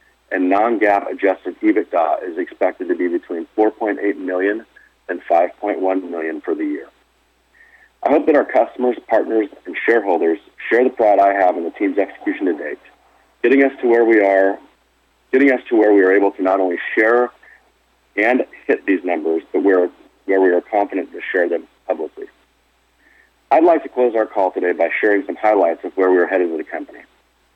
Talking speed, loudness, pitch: 185 wpm, -17 LUFS, 110 Hz